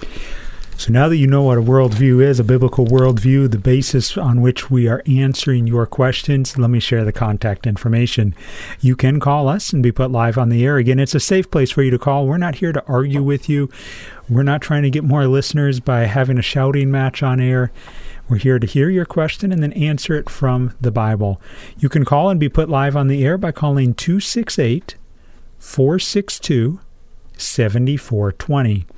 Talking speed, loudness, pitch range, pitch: 200 wpm, -16 LUFS, 120-145 Hz, 130 Hz